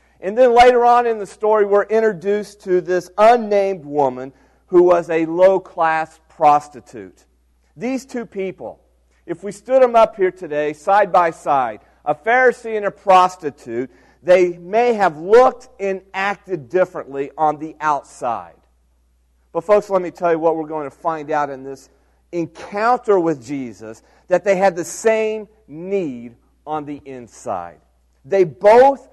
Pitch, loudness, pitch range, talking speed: 180 Hz, -17 LUFS, 145-205 Hz, 155 wpm